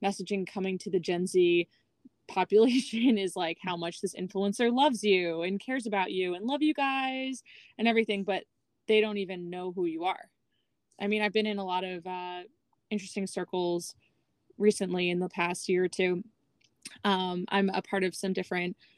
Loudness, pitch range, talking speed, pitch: -30 LUFS, 180-215 Hz, 185 wpm, 190 Hz